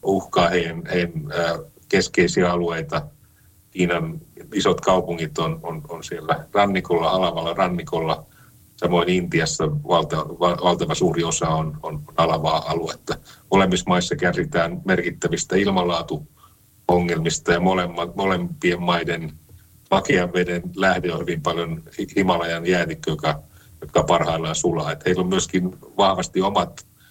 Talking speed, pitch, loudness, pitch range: 115 wpm, 85 Hz, -22 LUFS, 85-90 Hz